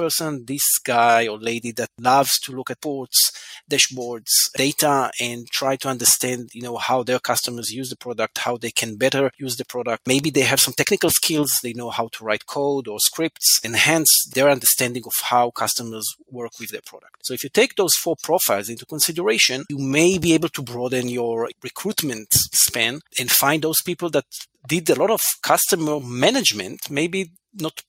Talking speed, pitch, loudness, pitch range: 185 wpm, 130 Hz, -19 LUFS, 120-150 Hz